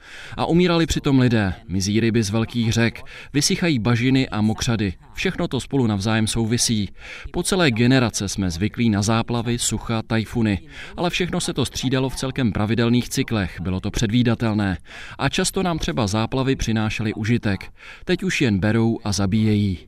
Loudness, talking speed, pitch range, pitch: -21 LUFS, 155 wpm, 105-130 Hz, 115 Hz